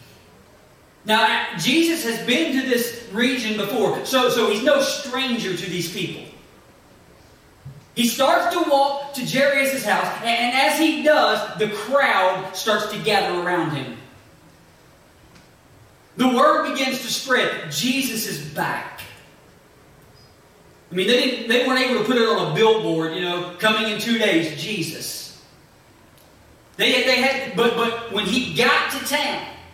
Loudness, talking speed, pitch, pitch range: -20 LUFS, 145 wpm, 235 Hz, 205-265 Hz